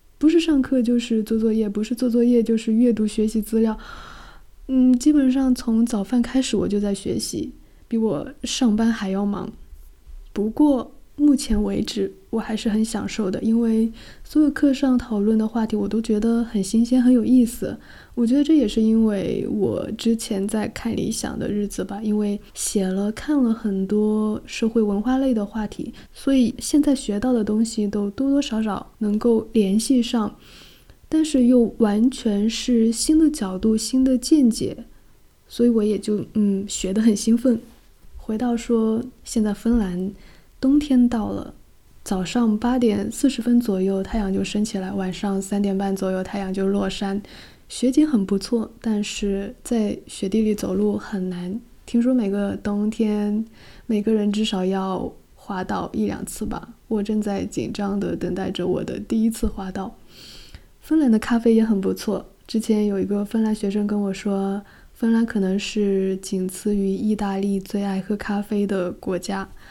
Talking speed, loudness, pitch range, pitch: 245 characters per minute, -22 LUFS, 200-240 Hz, 220 Hz